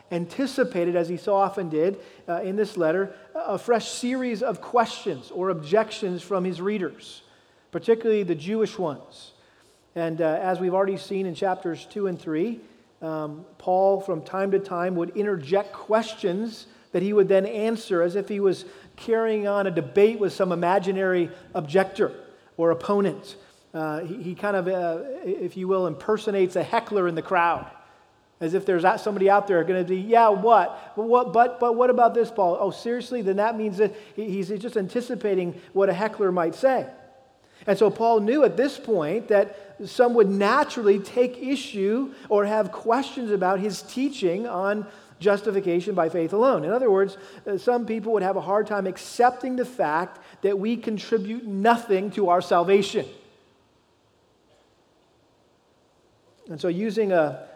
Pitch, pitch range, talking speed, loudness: 200 Hz, 185-220 Hz, 165 wpm, -24 LUFS